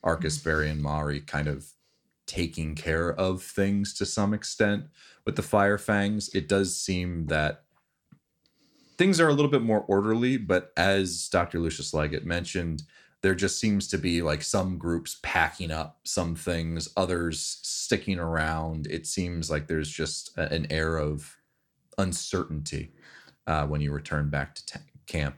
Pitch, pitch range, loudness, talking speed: 85 Hz, 75-100 Hz, -28 LUFS, 155 wpm